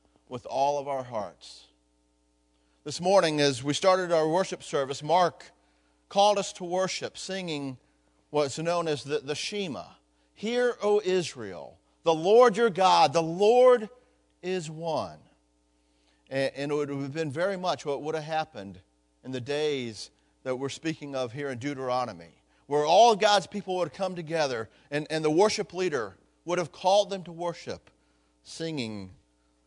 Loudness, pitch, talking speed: -27 LUFS, 150 Hz, 160 wpm